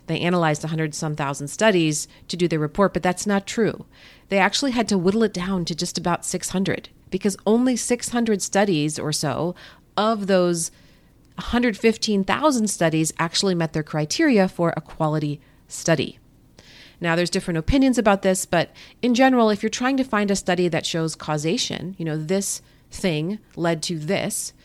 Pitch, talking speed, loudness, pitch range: 180 Hz, 170 wpm, -22 LUFS, 160-205 Hz